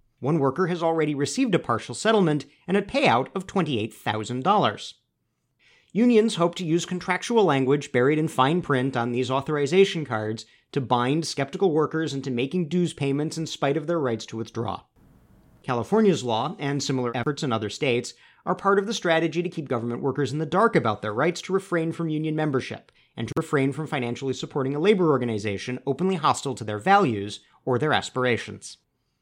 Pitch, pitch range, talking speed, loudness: 145 Hz, 125-175 Hz, 180 wpm, -24 LUFS